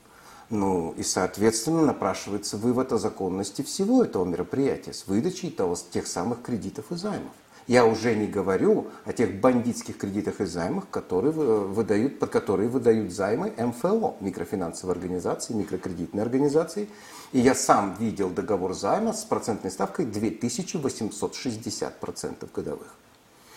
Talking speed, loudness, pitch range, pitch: 130 wpm, -26 LUFS, 100-145 Hz, 110 Hz